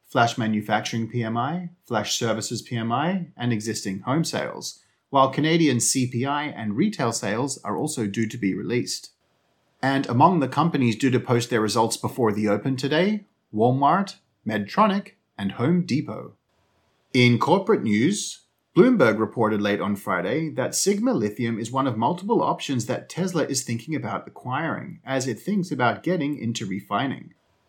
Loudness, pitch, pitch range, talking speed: -24 LUFS, 125 Hz, 110-150 Hz, 150 wpm